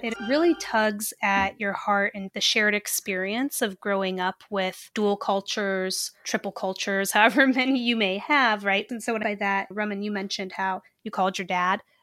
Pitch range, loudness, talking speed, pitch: 195-220 Hz, -25 LUFS, 180 wpm, 200 Hz